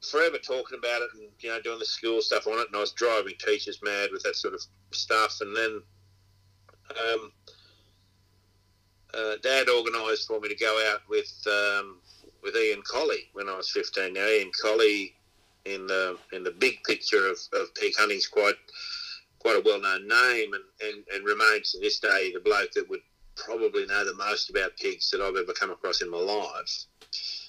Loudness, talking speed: -27 LUFS, 195 wpm